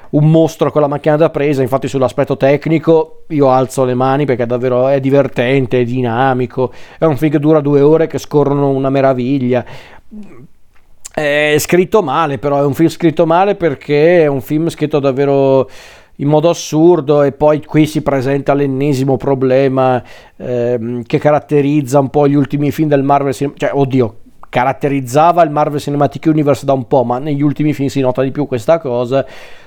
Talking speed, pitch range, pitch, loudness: 180 wpm, 130-150 Hz, 140 Hz, -13 LUFS